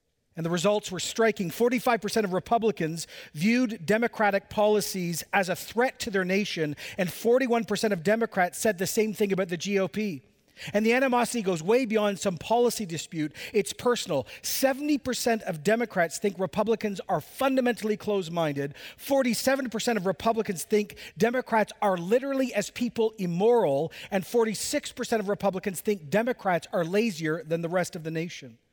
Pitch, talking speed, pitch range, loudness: 210 Hz, 150 wpm, 185-235 Hz, -27 LUFS